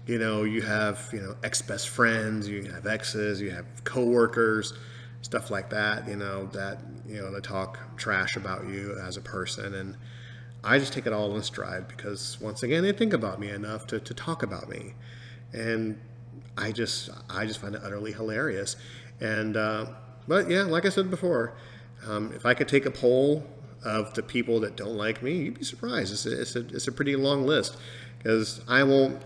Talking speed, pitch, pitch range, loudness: 200 wpm, 115 Hz, 105-125 Hz, -28 LUFS